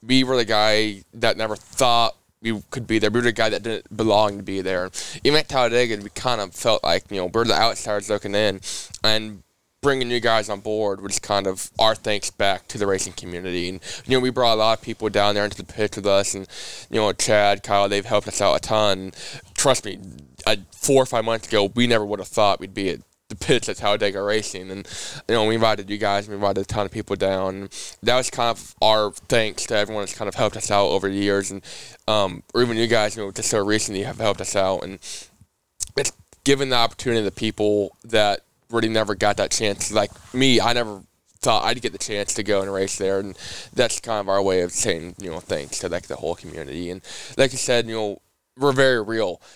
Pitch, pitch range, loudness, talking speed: 105 Hz, 100-115 Hz, -22 LUFS, 245 wpm